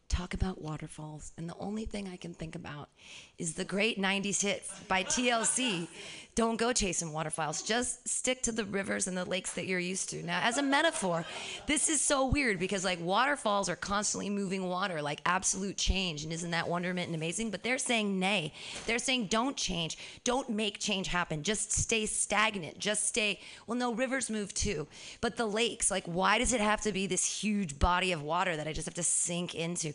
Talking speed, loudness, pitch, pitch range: 205 wpm, -31 LUFS, 195 Hz, 175-225 Hz